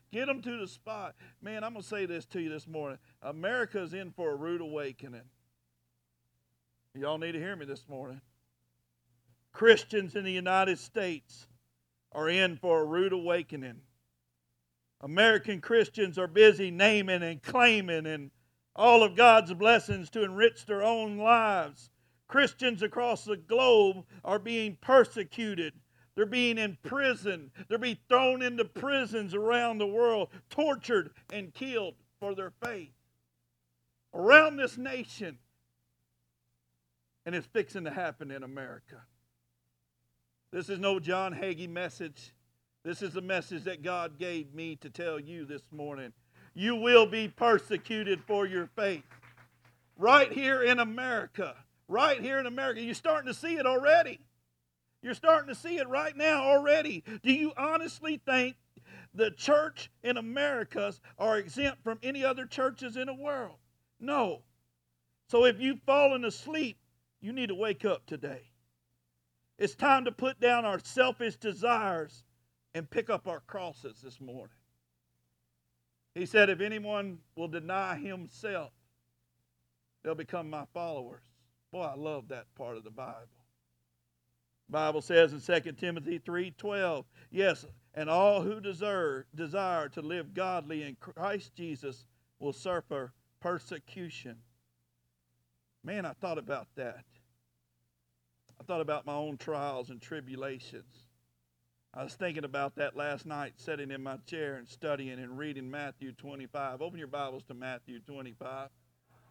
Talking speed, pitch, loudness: 140 wpm, 165 Hz, -29 LUFS